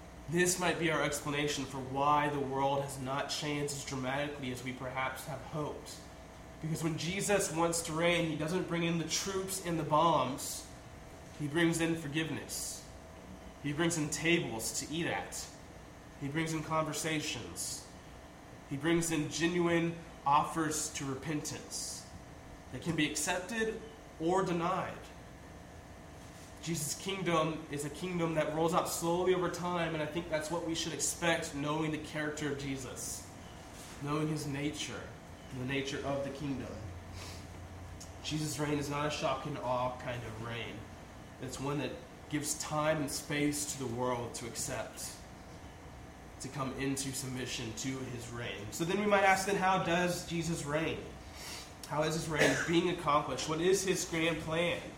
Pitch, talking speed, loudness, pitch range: 150 Hz, 160 wpm, -34 LUFS, 135-165 Hz